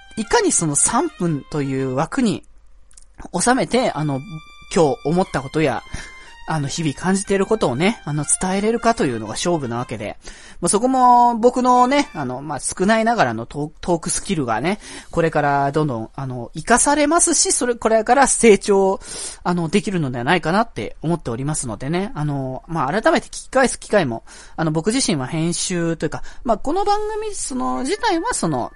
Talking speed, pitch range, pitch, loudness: 355 characters per minute, 150-245 Hz, 175 Hz, -19 LUFS